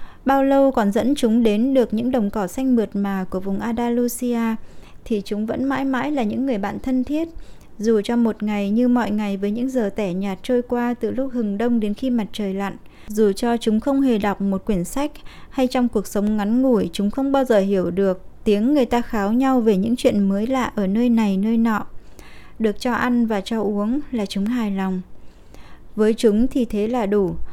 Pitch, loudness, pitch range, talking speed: 225 Hz, -21 LUFS, 205-250 Hz, 220 wpm